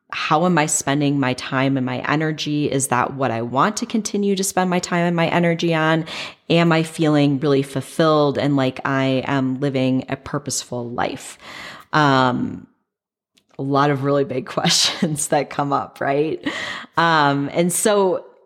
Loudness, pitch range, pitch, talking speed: -19 LUFS, 135-165 Hz, 145 Hz, 165 wpm